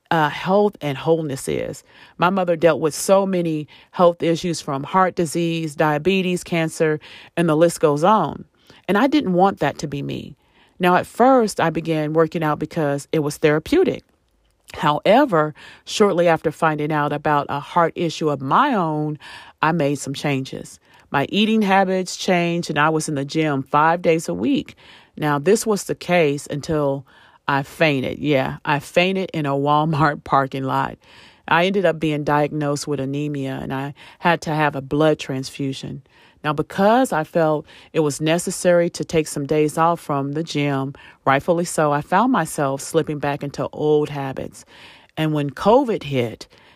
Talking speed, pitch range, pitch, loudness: 170 wpm, 145-170 Hz, 155 Hz, -20 LUFS